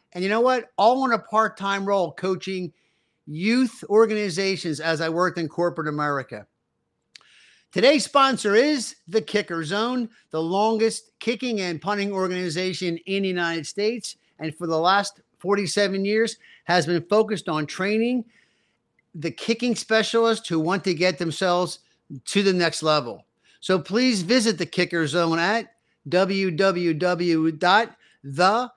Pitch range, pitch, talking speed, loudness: 170-220 Hz, 190 Hz, 140 wpm, -23 LUFS